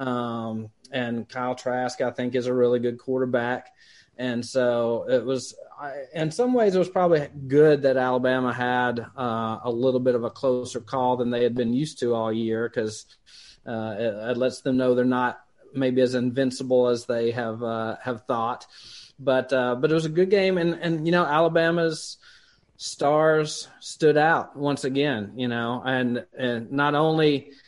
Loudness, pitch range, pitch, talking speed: -24 LUFS, 120-145 Hz, 125 Hz, 180 wpm